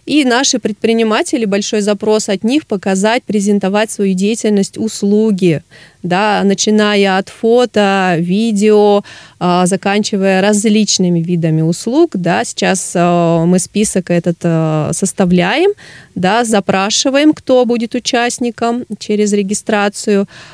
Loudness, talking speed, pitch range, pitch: -13 LUFS, 100 wpm, 190-225 Hz, 205 Hz